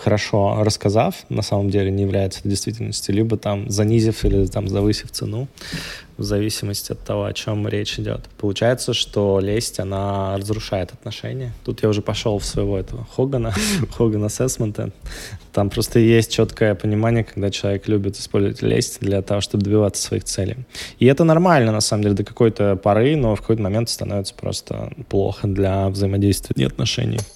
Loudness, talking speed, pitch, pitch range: -20 LUFS, 165 wpm, 105 Hz, 100-115 Hz